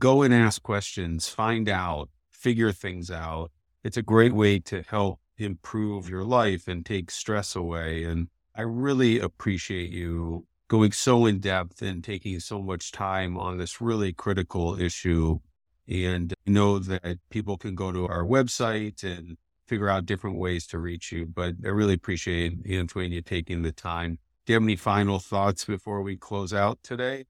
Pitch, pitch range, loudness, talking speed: 95 Hz, 85-105 Hz, -27 LUFS, 175 wpm